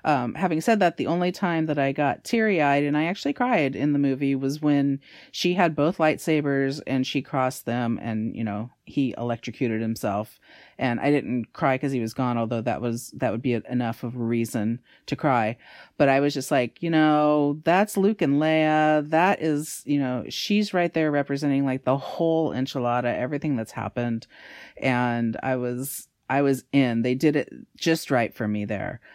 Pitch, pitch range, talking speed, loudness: 140 Hz, 120-155 Hz, 195 wpm, -24 LUFS